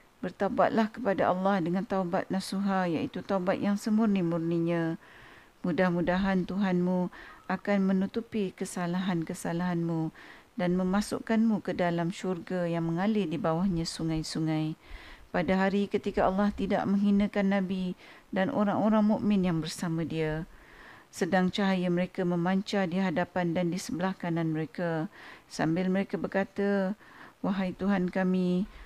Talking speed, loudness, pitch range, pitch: 115 wpm, -29 LUFS, 175-200 Hz, 185 Hz